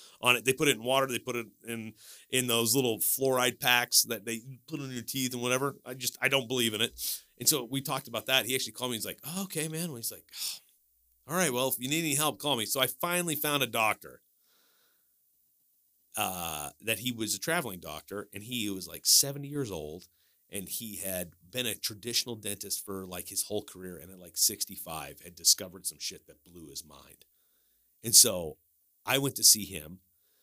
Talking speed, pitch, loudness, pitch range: 220 wpm, 115 Hz, -29 LUFS, 100-130 Hz